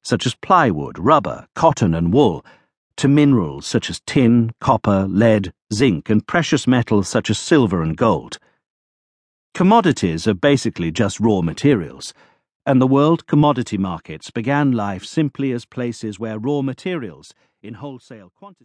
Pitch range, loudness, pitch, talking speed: 100-140 Hz, -18 LUFS, 120 Hz, 145 wpm